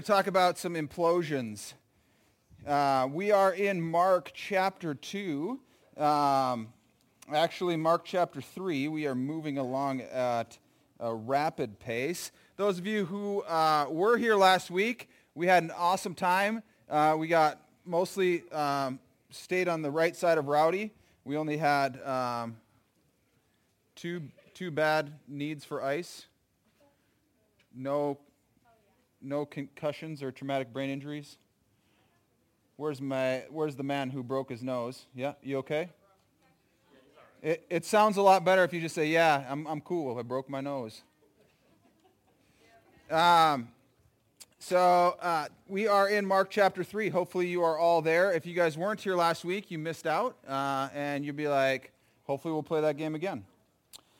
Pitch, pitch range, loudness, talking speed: 155 Hz, 135-180 Hz, -29 LUFS, 145 wpm